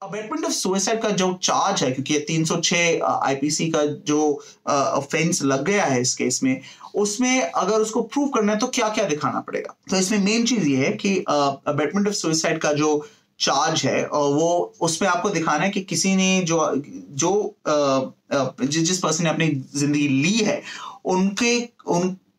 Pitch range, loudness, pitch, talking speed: 150-210 Hz, -21 LUFS, 175 Hz, 175 wpm